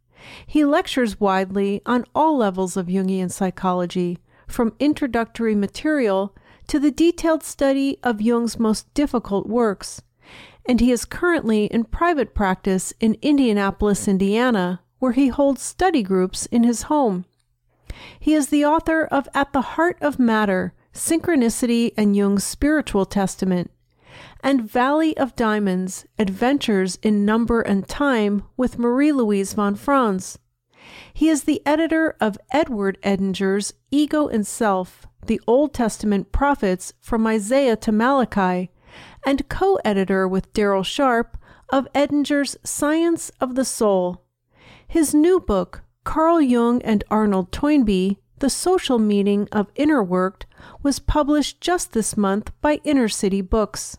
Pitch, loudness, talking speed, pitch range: 230 Hz, -20 LUFS, 135 wpm, 195-280 Hz